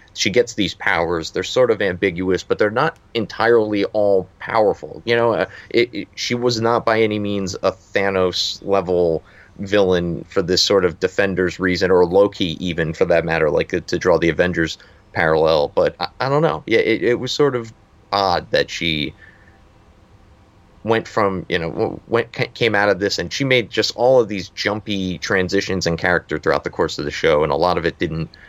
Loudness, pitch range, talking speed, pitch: -19 LUFS, 90-120 Hz, 200 wpm, 100 Hz